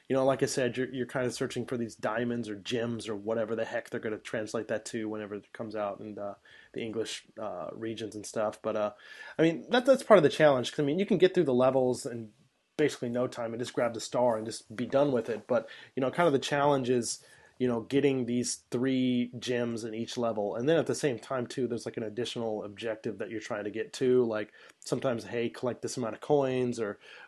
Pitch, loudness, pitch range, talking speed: 120 Hz, -30 LUFS, 110-130 Hz, 255 wpm